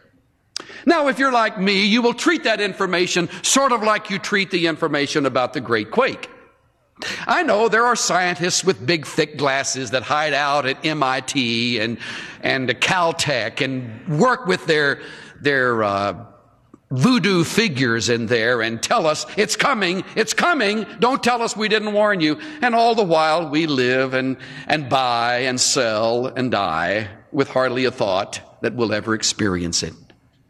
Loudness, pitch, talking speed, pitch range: -19 LUFS, 155 Hz, 165 wpm, 125-210 Hz